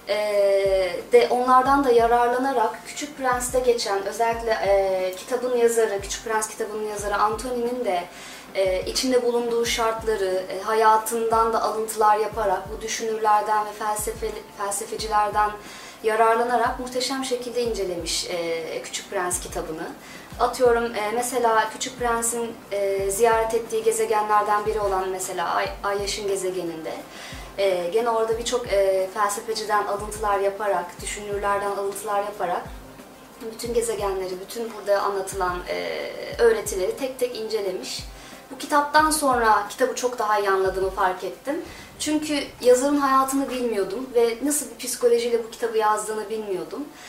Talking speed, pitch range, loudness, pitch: 125 wpm, 200-245 Hz, -23 LUFS, 220 Hz